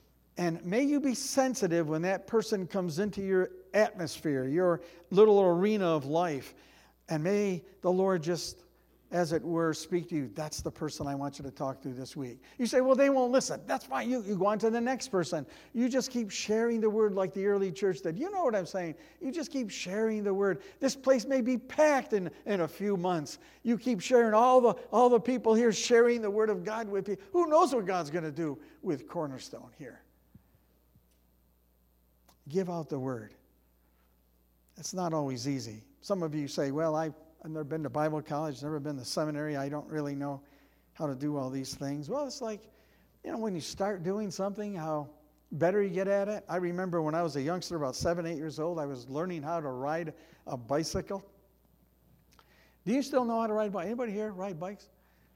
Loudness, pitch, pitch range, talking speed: -31 LUFS, 180 Hz, 150-215 Hz, 210 wpm